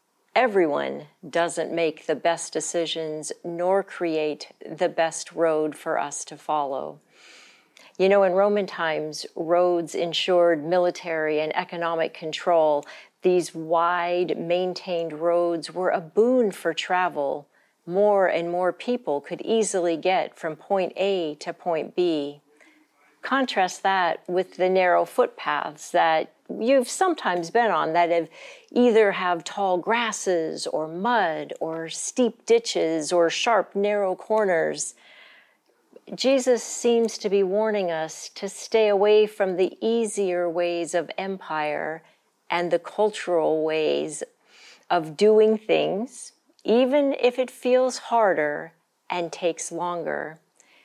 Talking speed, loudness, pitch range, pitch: 125 wpm, -24 LUFS, 165-205 Hz, 175 Hz